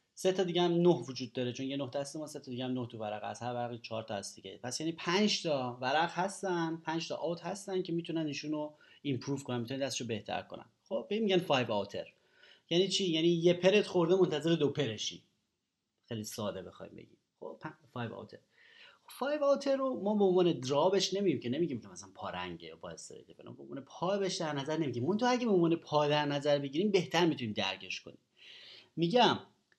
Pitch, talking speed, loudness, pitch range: 155 Hz, 185 wpm, -33 LUFS, 125-185 Hz